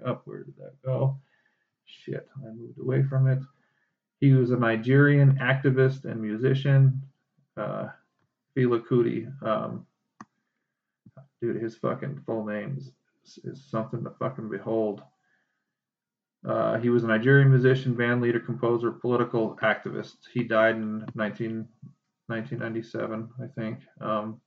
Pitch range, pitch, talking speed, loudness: 115-135 Hz, 120 Hz, 130 wpm, -26 LUFS